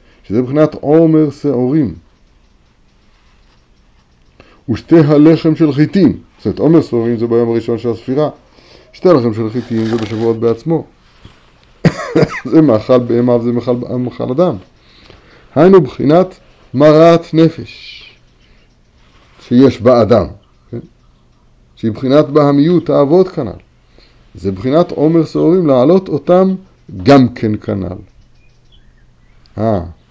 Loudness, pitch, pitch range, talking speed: -12 LUFS, 120 Hz, 100-155 Hz, 105 wpm